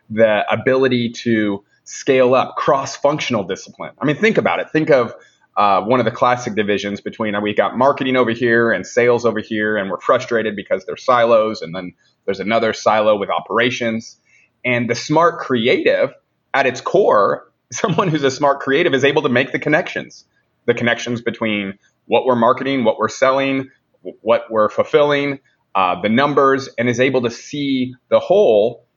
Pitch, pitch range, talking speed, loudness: 120 Hz, 110-135 Hz, 180 wpm, -17 LUFS